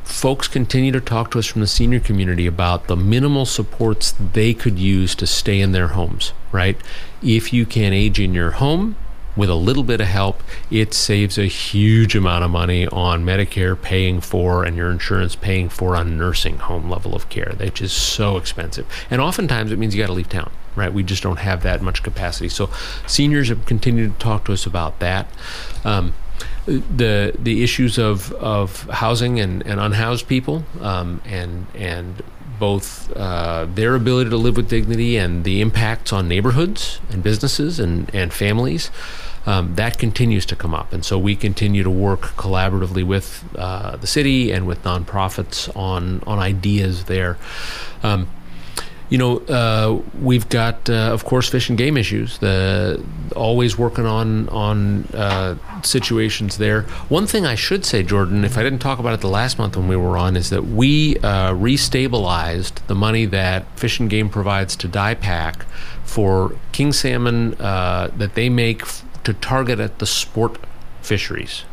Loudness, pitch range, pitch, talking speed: -19 LUFS, 90-115 Hz, 100 Hz, 180 wpm